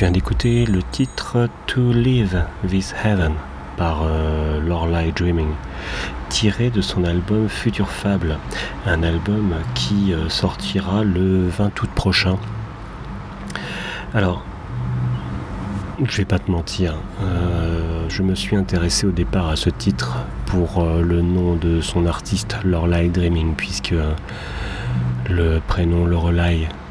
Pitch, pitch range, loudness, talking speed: 90 Hz, 80-100 Hz, -20 LUFS, 125 wpm